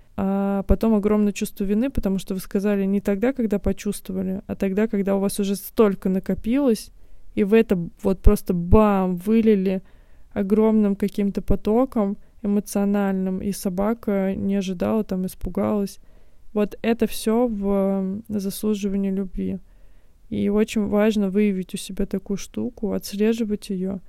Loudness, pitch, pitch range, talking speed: -23 LUFS, 200 Hz, 195-210 Hz, 135 wpm